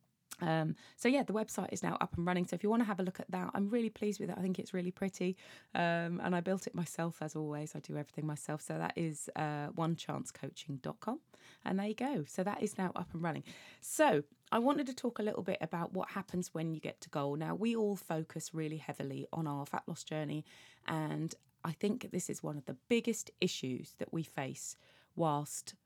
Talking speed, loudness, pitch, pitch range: 230 wpm, -38 LUFS, 175 Hz, 155-205 Hz